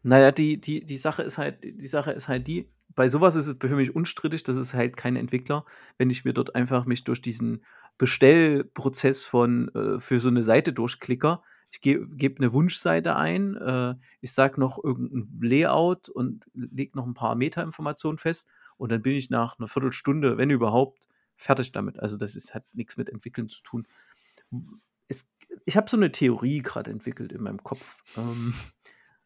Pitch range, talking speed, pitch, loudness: 125-150 Hz, 185 wpm, 130 Hz, -25 LUFS